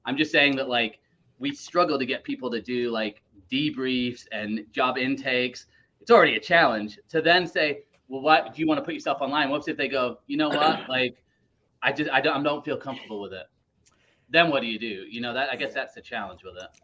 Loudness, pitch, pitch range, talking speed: -25 LUFS, 130 Hz, 115-150 Hz, 235 wpm